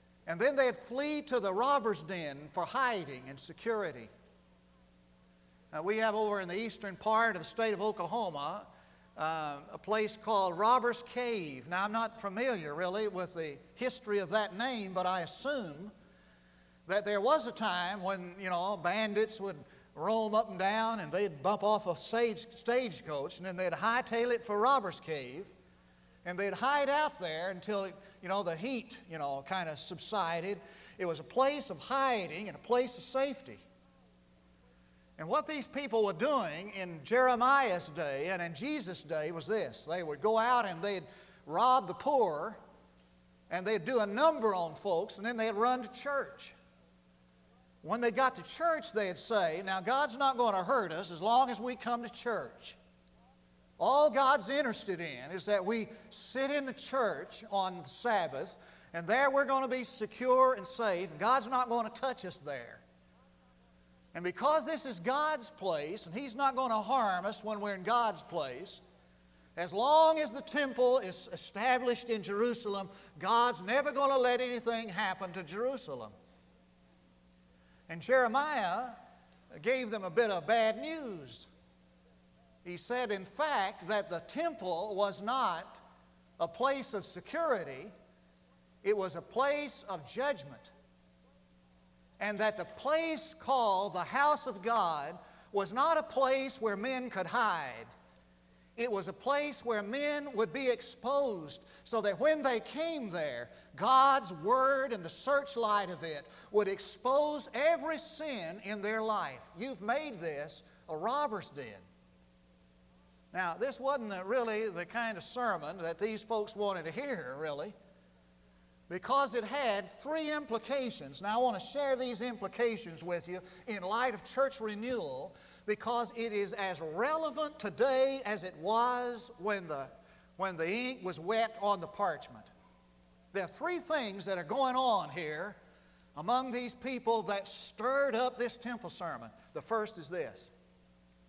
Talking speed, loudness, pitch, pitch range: 160 wpm, -33 LUFS, 210 Hz, 170-250 Hz